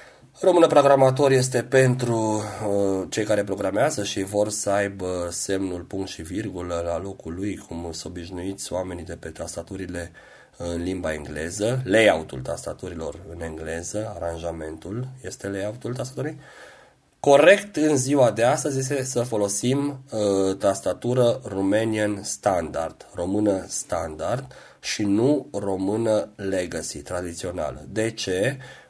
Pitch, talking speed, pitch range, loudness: 100 Hz, 125 wpm, 90-120 Hz, -24 LUFS